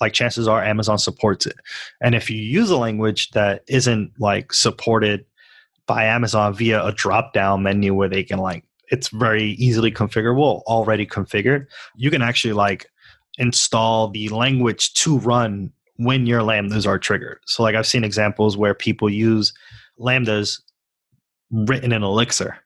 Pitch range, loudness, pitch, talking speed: 105-120 Hz, -19 LUFS, 110 Hz, 155 wpm